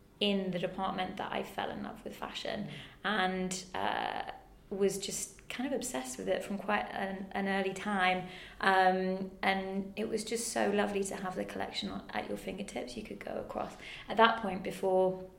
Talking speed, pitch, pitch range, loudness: 185 wpm, 195 Hz, 185-200 Hz, -34 LUFS